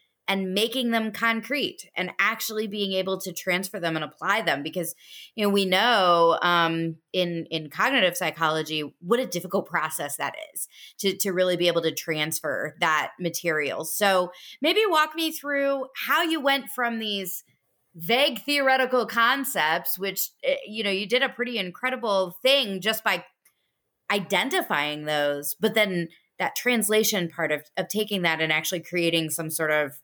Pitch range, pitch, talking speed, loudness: 165-230 Hz, 190 Hz, 160 wpm, -24 LUFS